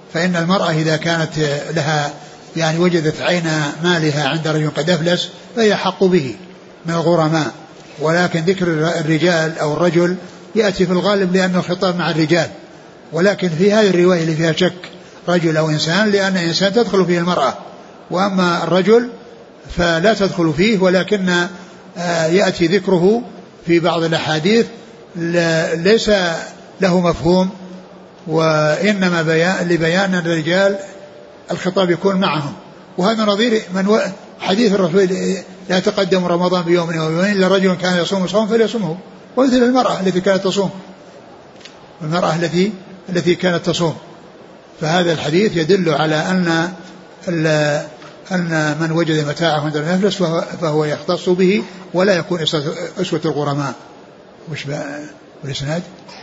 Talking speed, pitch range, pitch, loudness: 120 wpm, 165-190 Hz, 175 Hz, -16 LUFS